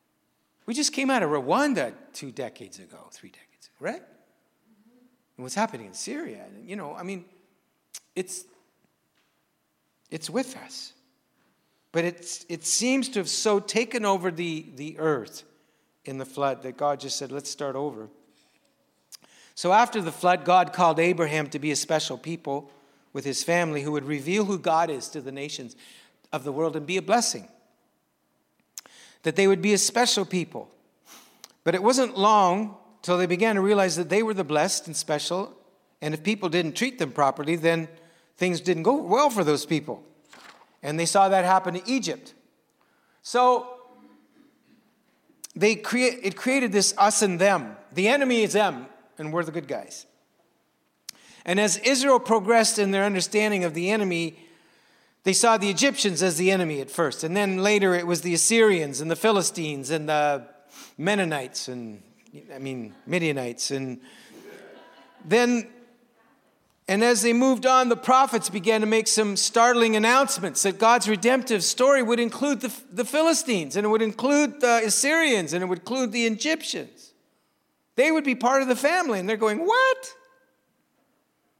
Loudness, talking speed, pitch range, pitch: -23 LUFS, 165 wpm, 165-235 Hz, 195 Hz